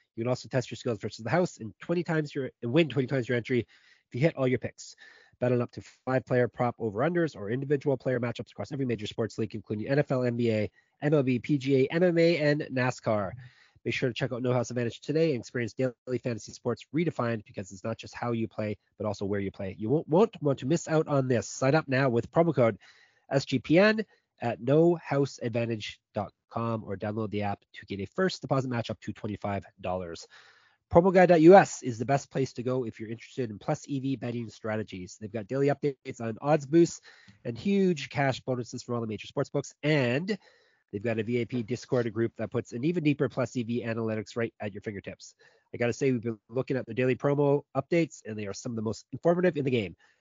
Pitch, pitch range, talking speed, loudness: 125 Hz, 115-140 Hz, 215 wpm, -29 LUFS